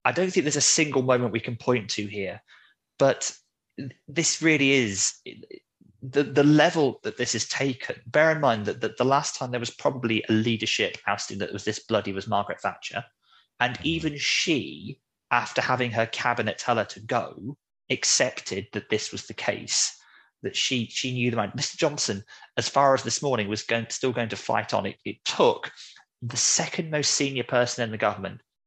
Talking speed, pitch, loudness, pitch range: 195 wpm, 125 Hz, -25 LUFS, 110-140 Hz